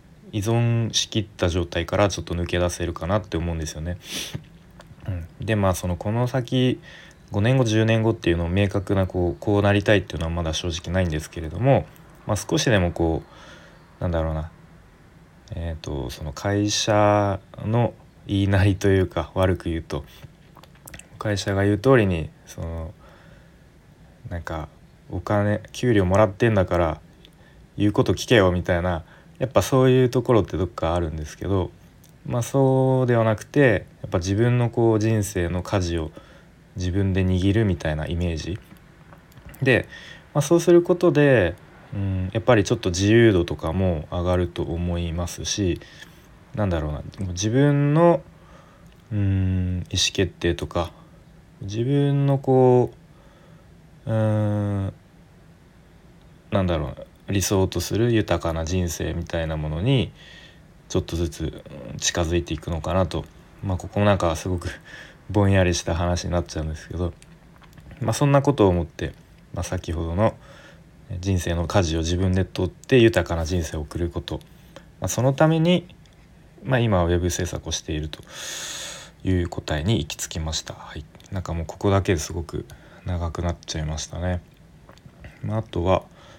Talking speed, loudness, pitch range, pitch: 305 characters per minute, -23 LUFS, 85-110 Hz, 95 Hz